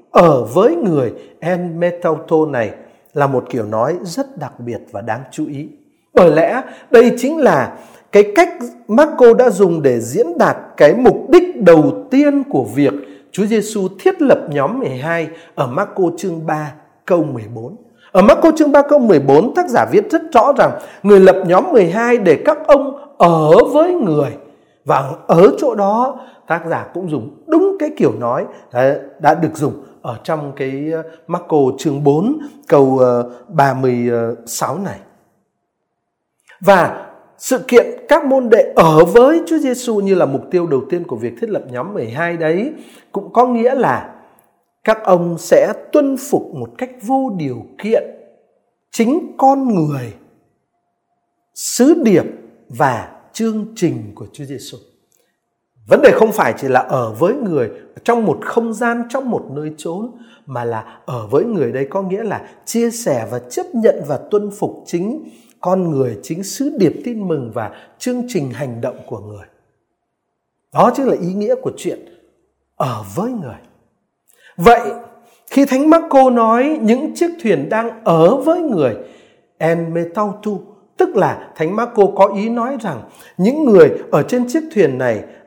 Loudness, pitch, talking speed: -14 LUFS, 210 Hz, 165 wpm